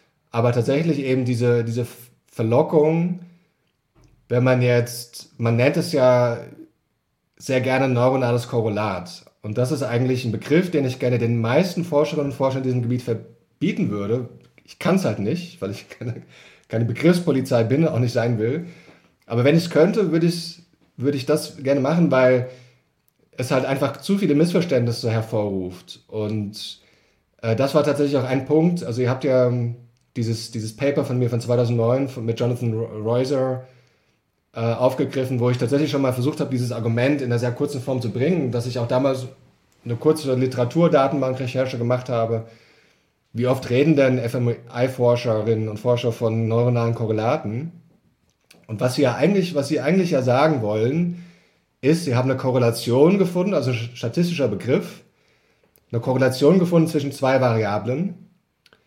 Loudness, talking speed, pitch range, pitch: -21 LUFS, 160 wpm, 120-145 Hz, 130 Hz